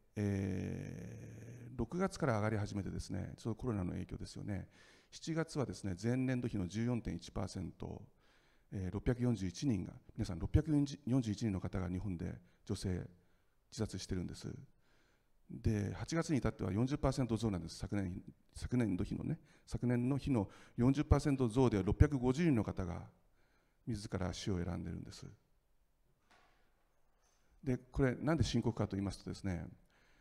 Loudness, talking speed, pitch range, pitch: -38 LUFS, 235 characters per minute, 95-125 Hz, 110 Hz